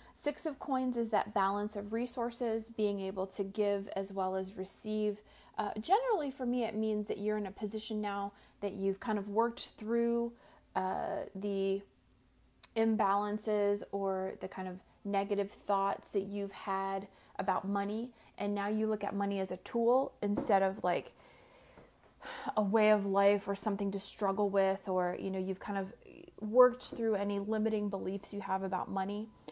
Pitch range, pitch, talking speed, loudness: 195-225 Hz, 205 Hz, 170 wpm, -35 LUFS